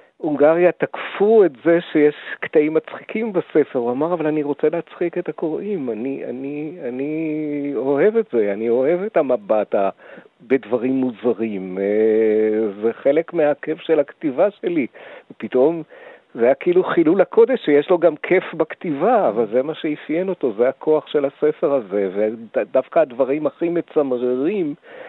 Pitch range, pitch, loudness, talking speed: 130-175 Hz, 155 Hz, -19 LUFS, 145 wpm